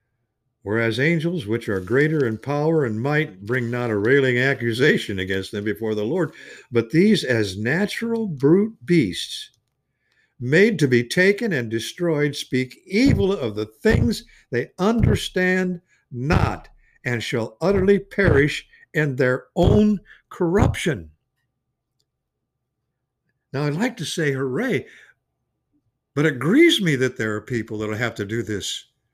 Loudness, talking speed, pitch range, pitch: -21 LUFS, 135 wpm, 115-165 Hz, 130 Hz